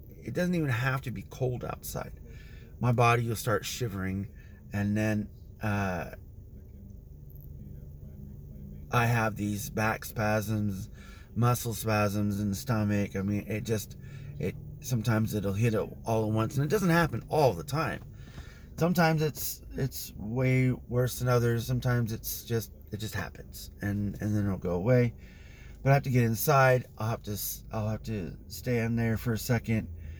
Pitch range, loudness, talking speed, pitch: 100-125 Hz, -30 LUFS, 165 wpm, 110 Hz